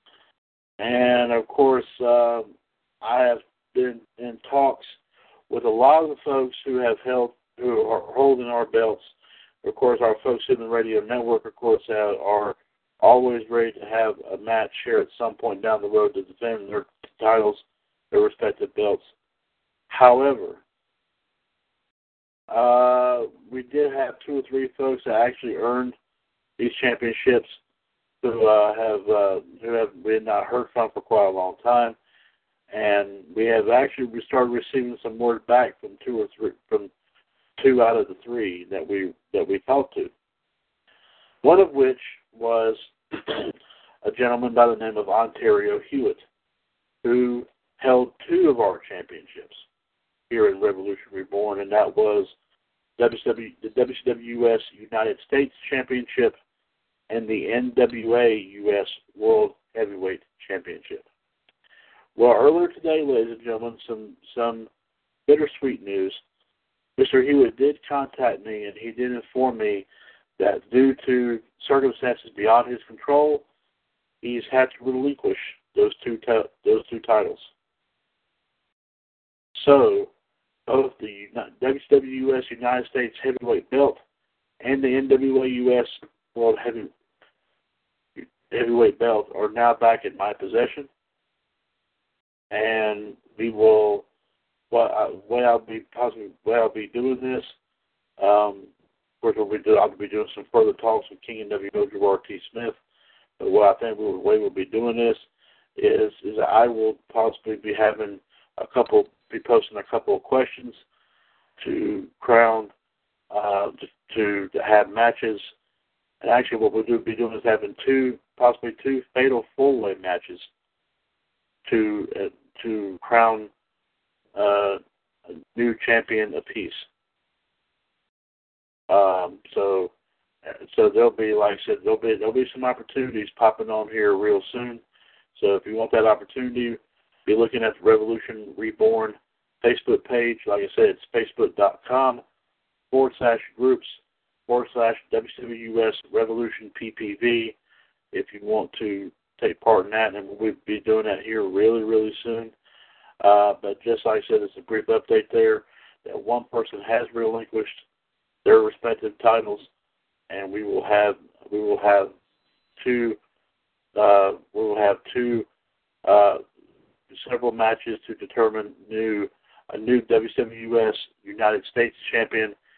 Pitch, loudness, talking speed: 125 Hz, -22 LUFS, 140 wpm